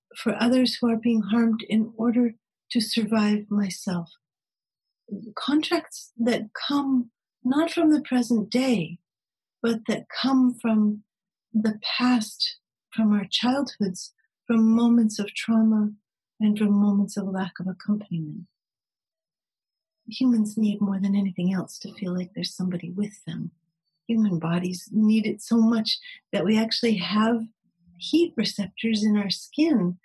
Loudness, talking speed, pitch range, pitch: -24 LUFS, 135 wpm, 200-235 Hz, 215 Hz